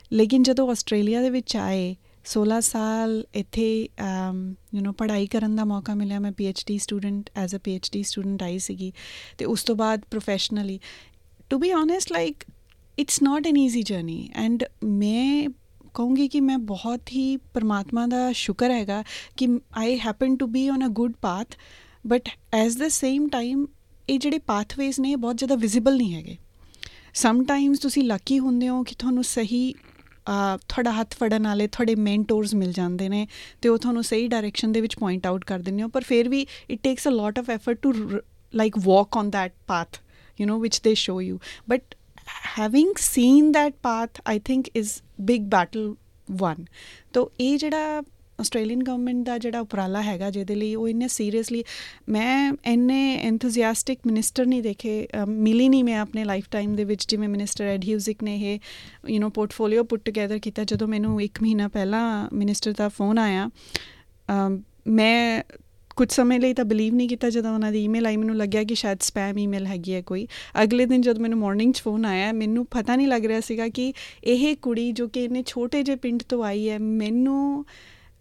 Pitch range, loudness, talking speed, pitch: 210-250 Hz, -24 LUFS, 175 wpm, 225 Hz